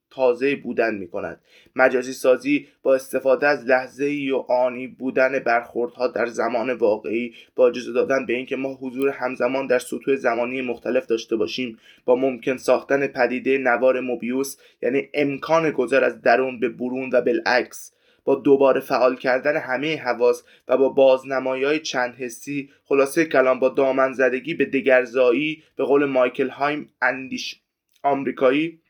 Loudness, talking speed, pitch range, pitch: -21 LUFS, 150 wpm, 125-140 Hz, 130 Hz